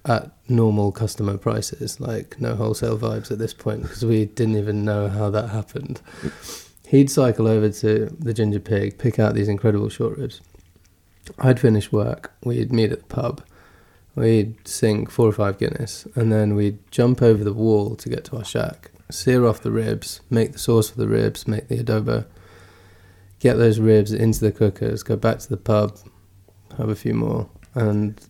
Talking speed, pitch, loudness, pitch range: 185 wpm, 110 Hz, -21 LUFS, 105-115 Hz